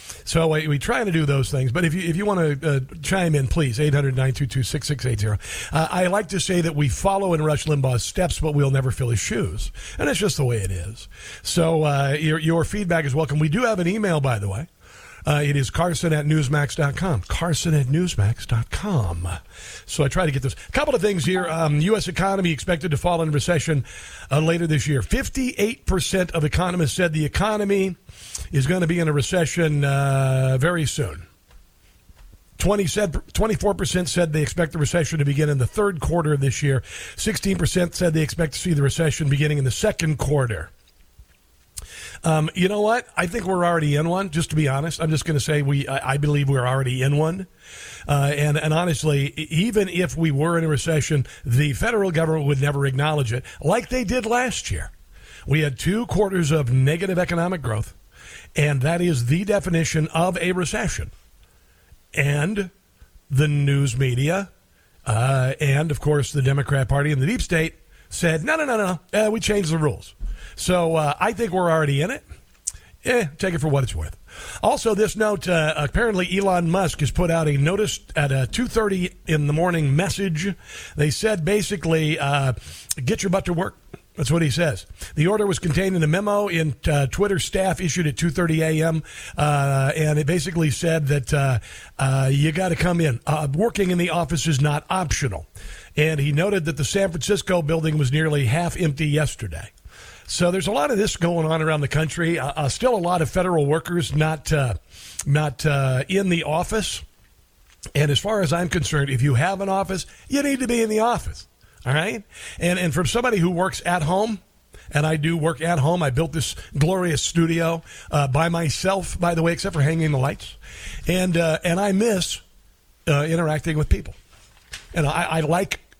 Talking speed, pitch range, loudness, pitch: 195 wpm, 140-180 Hz, -22 LUFS, 160 Hz